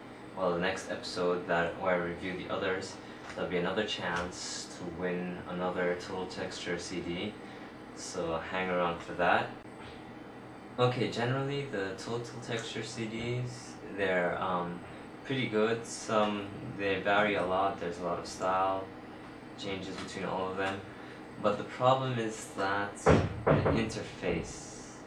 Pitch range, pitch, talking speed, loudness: 85-105 Hz, 95 Hz, 135 wpm, -33 LUFS